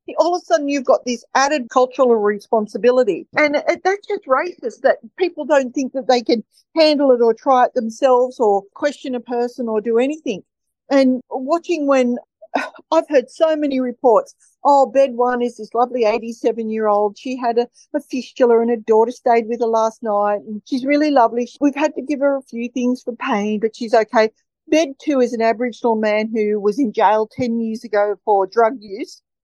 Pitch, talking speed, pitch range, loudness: 250 Hz, 200 wpm, 230-285 Hz, -18 LUFS